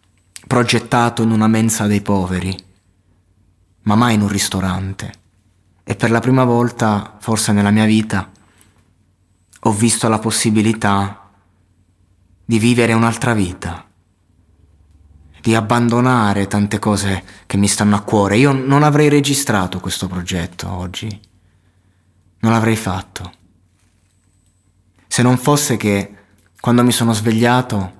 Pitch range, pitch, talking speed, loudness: 95-115 Hz, 100 Hz, 120 wpm, -15 LUFS